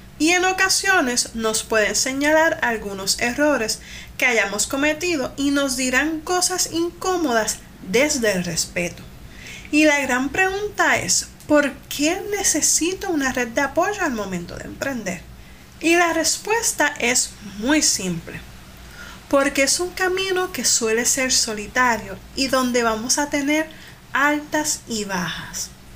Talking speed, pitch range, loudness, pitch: 130 wpm, 225-330 Hz, -20 LUFS, 280 Hz